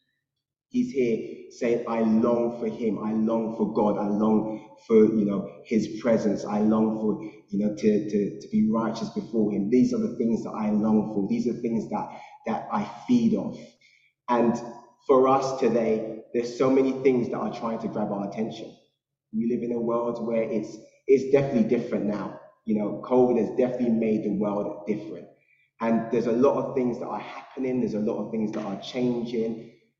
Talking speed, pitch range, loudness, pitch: 195 wpm, 110-125 Hz, -26 LUFS, 115 Hz